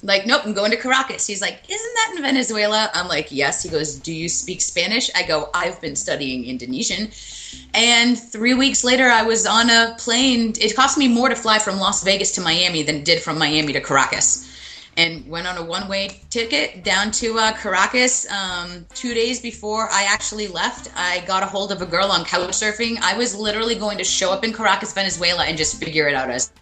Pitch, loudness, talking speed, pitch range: 200 Hz, -18 LUFS, 220 wpm, 170-230 Hz